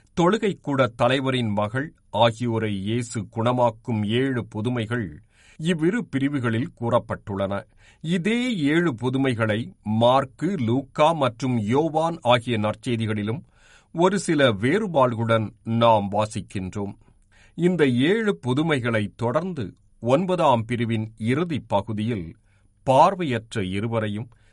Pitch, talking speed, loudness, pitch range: 120 Hz, 85 wpm, -23 LUFS, 110-140 Hz